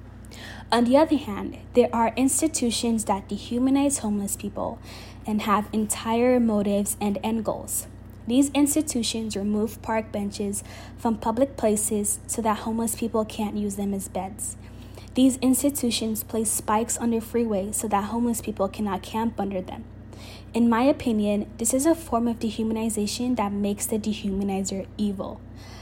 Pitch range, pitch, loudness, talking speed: 200-235 Hz, 220 Hz, -25 LUFS, 150 wpm